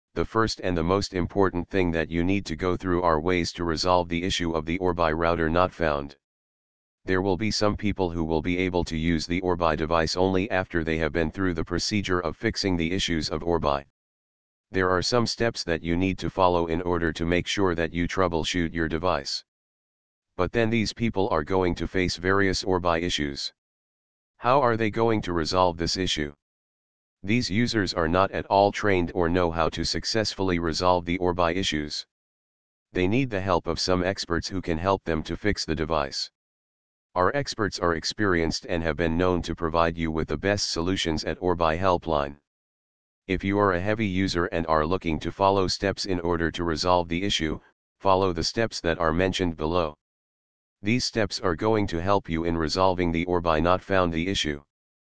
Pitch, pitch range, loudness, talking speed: 90 Hz, 80-95 Hz, -25 LUFS, 195 wpm